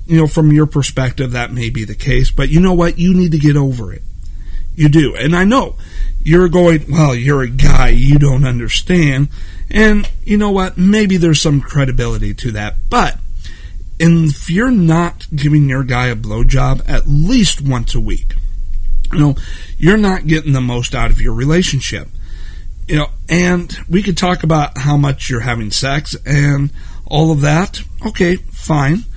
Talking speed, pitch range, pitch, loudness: 180 wpm, 120-165 Hz, 145 Hz, -13 LUFS